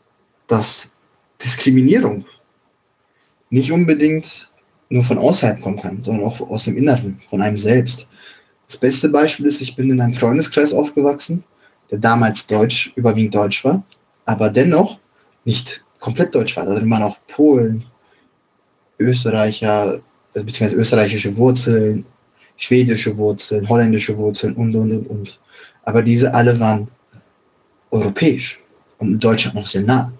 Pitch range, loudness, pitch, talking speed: 105-130 Hz, -17 LUFS, 115 Hz, 135 wpm